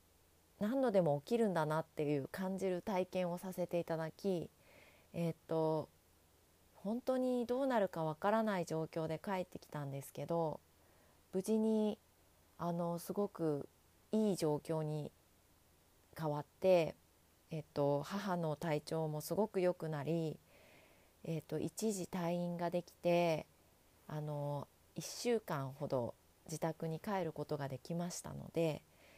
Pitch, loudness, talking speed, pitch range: 160 Hz, -39 LUFS, 245 characters per minute, 145-185 Hz